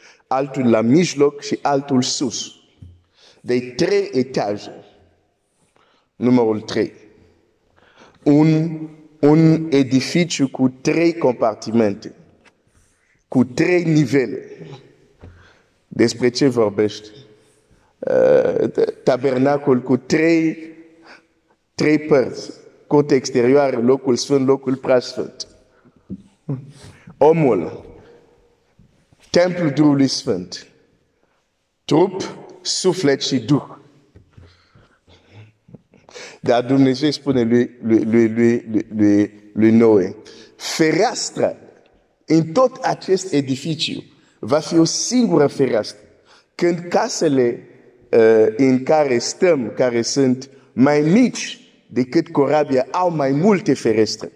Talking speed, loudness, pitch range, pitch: 85 wpm, -17 LUFS, 120-160 Hz, 140 Hz